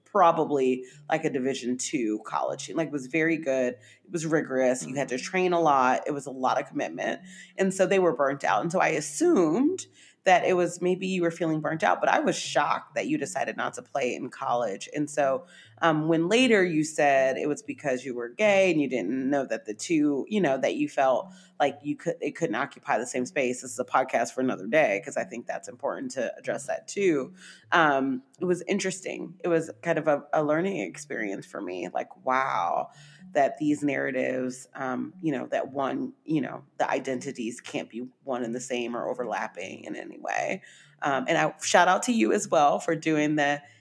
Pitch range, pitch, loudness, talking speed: 130-175 Hz, 150 Hz, -27 LUFS, 215 wpm